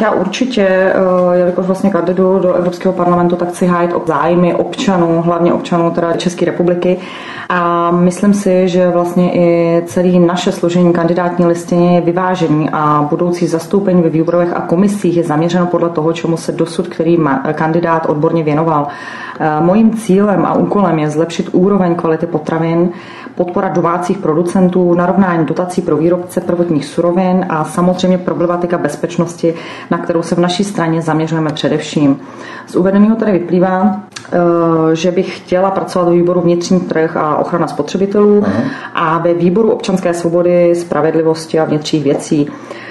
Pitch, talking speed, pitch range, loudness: 175 Hz, 150 wpm, 165-185 Hz, -13 LUFS